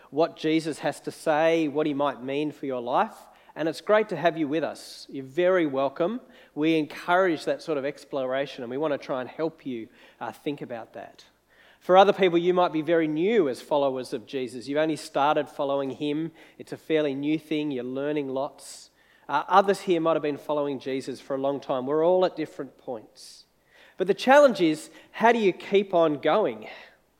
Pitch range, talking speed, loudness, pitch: 140-170 Hz, 205 wpm, -25 LUFS, 155 Hz